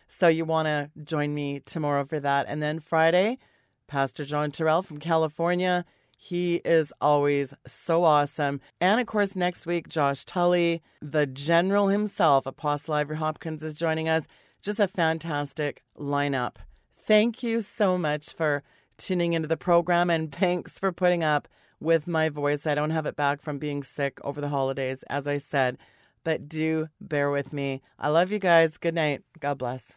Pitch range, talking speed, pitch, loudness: 145-170 Hz, 170 wpm, 155 Hz, -26 LUFS